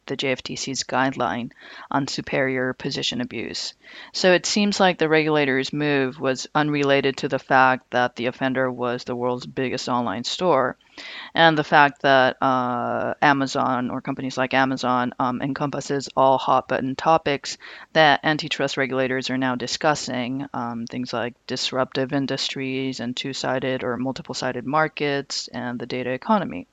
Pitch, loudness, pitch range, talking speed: 130 Hz, -22 LUFS, 125-140 Hz, 145 wpm